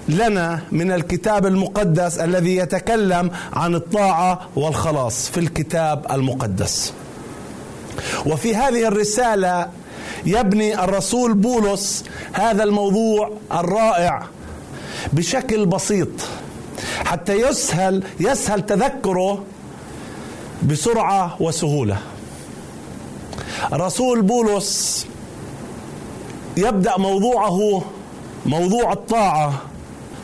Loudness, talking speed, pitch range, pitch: -19 LUFS, 70 wpm, 165-210 Hz, 190 Hz